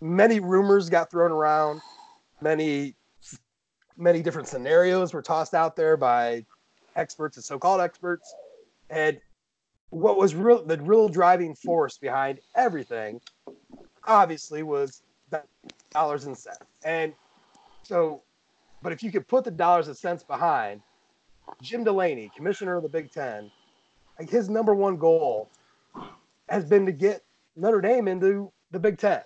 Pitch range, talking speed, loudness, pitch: 155-200 Hz, 140 wpm, -24 LUFS, 175 Hz